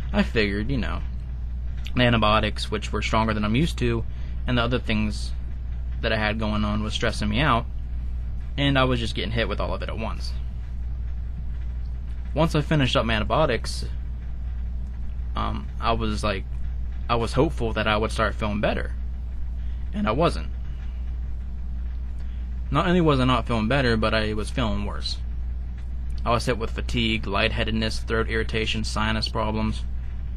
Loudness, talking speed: -26 LUFS, 160 wpm